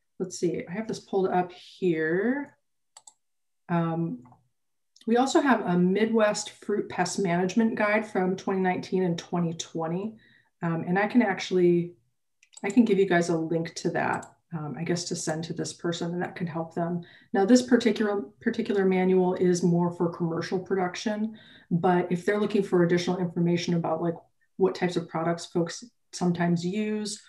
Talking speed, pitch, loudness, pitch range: 165 wpm, 180 Hz, -27 LUFS, 170-210 Hz